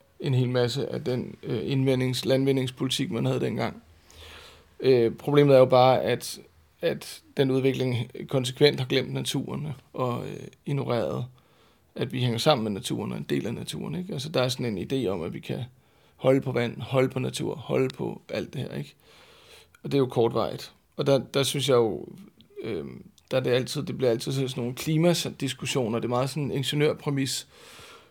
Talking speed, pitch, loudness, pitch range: 185 wpm, 130 Hz, -26 LUFS, 125-140 Hz